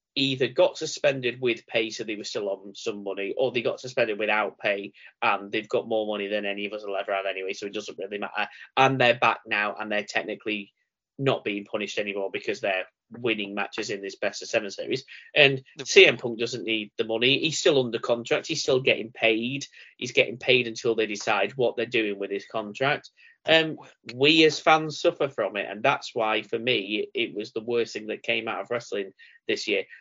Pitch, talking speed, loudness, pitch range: 115 Hz, 220 wpm, -25 LUFS, 105-145 Hz